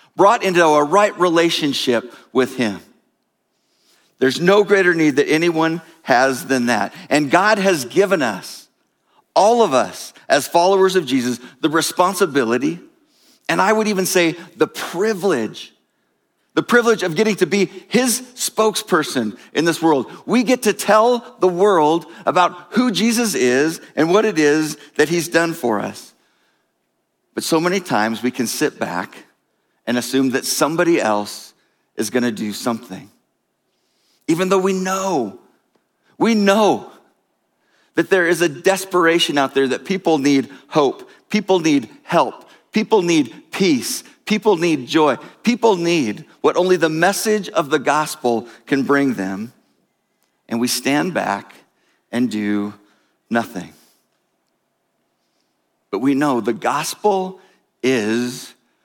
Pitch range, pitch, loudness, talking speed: 135-205 Hz, 170 Hz, -17 LUFS, 140 wpm